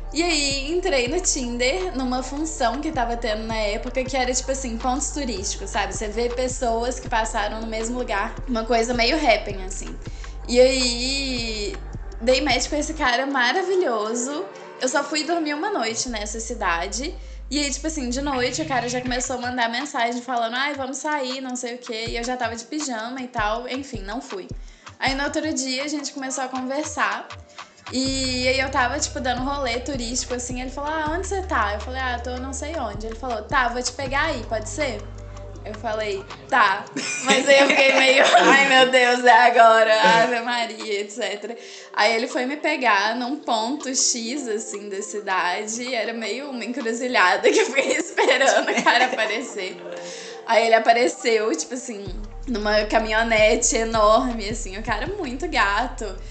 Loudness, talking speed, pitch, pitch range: -21 LUFS, 185 wpm, 250 Hz, 225-275 Hz